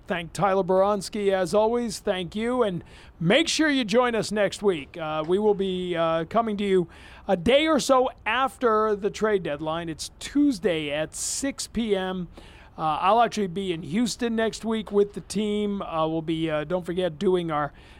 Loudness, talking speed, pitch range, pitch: -25 LUFS, 185 wpm, 175-220 Hz, 200 Hz